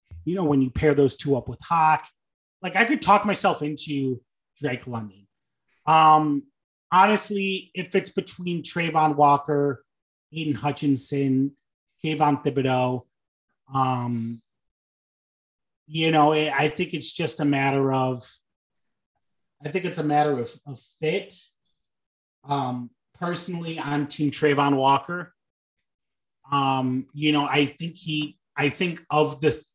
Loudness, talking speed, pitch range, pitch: -23 LUFS, 130 wpm, 135-160 Hz, 145 Hz